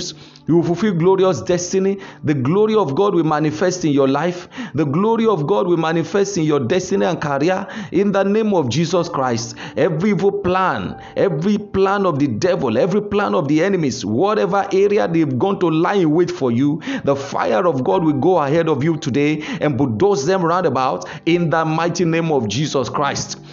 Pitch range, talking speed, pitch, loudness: 150-195 Hz, 195 wpm, 175 Hz, -17 LUFS